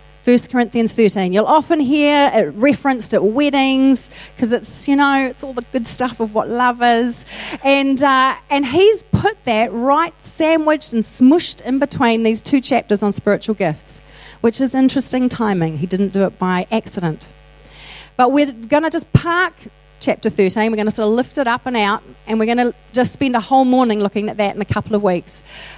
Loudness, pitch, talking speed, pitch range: -16 LUFS, 245 Hz, 200 wpm, 215-275 Hz